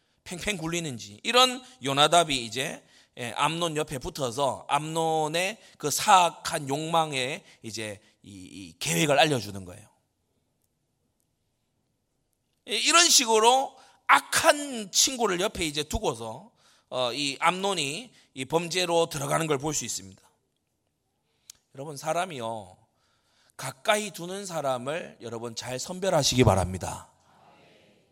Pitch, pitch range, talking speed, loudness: 145 Hz, 125-180 Hz, 230 characters per minute, -25 LUFS